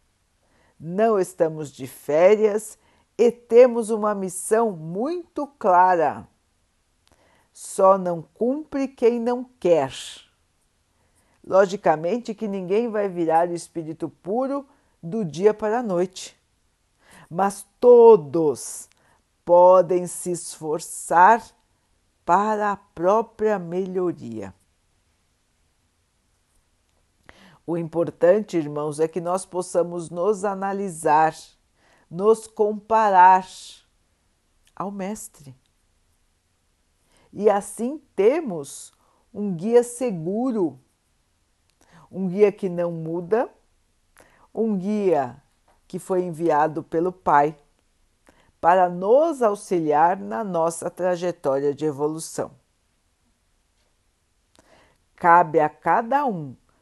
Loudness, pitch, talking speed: -21 LUFS, 175 Hz, 85 wpm